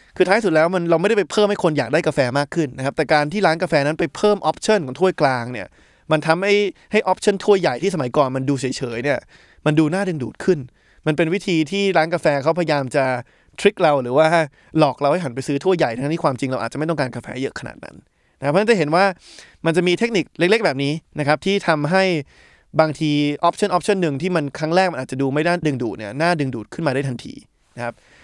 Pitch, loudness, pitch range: 160 Hz, -19 LUFS, 140-185 Hz